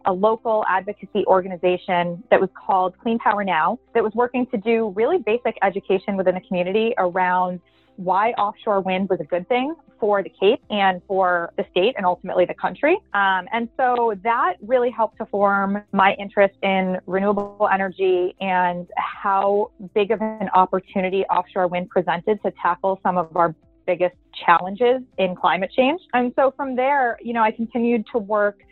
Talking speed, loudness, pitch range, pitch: 170 wpm, -21 LUFS, 185-225 Hz, 195 Hz